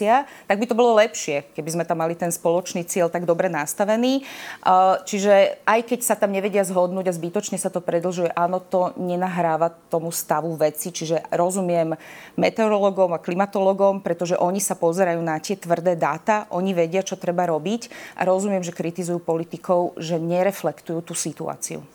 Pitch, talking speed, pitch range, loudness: 180 Hz, 165 wpm, 170-195 Hz, -22 LUFS